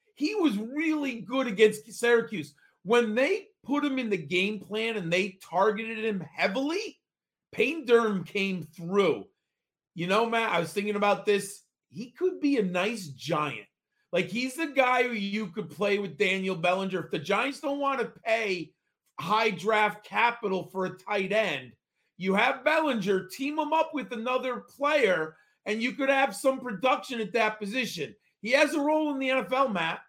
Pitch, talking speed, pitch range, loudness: 220 Hz, 175 wpm, 190-260 Hz, -28 LUFS